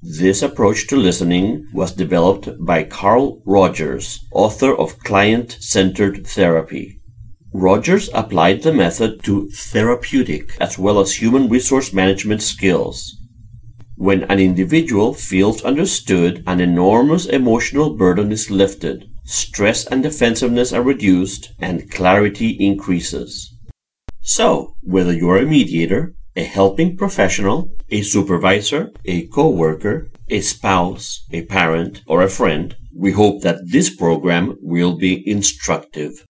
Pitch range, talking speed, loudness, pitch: 90-110 Hz, 120 wpm, -16 LUFS, 100 Hz